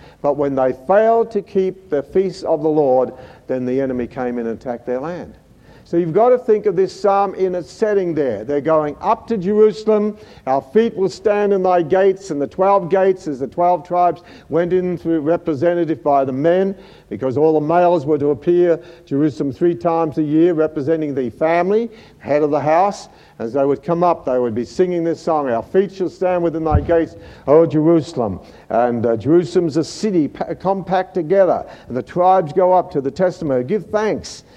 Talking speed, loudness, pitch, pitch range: 200 wpm, -17 LUFS, 170 Hz, 145-190 Hz